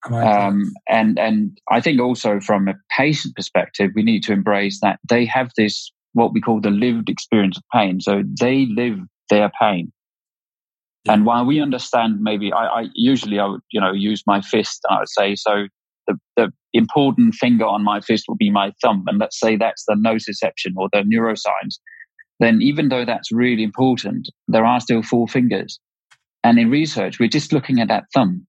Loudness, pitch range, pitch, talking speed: -18 LUFS, 105-130 Hz, 115 Hz, 190 wpm